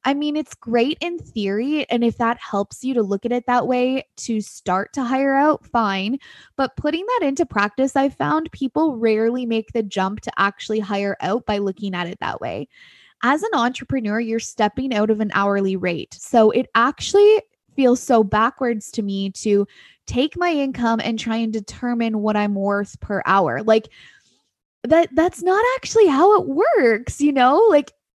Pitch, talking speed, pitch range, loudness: 235 Hz, 185 wpm, 210-275 Hz, -20 LUFS